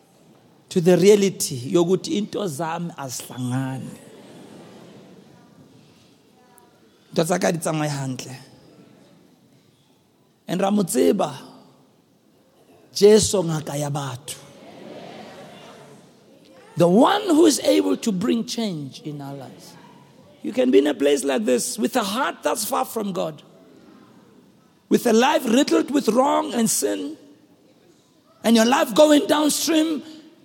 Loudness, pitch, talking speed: -20 LUFS, 185 Hz, 95 wpm